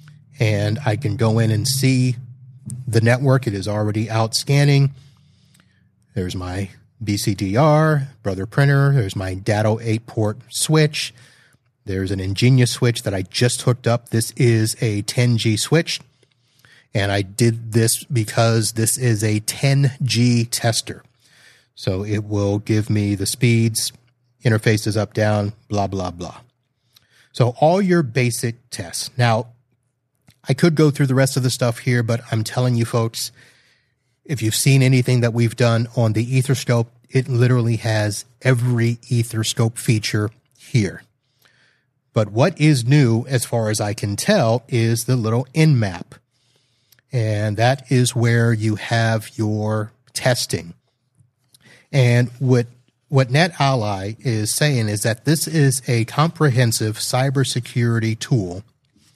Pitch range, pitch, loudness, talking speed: 110-130 Hz, 120 Hz, -19 LUFS, 140 wpm